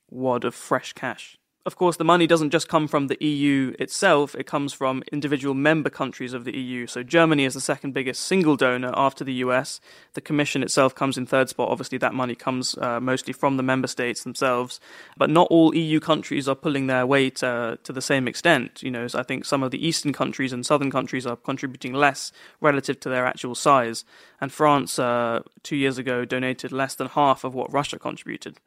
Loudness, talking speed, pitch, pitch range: -23 LUFS, 210 wpm, 135 Hz, 125-150 Hz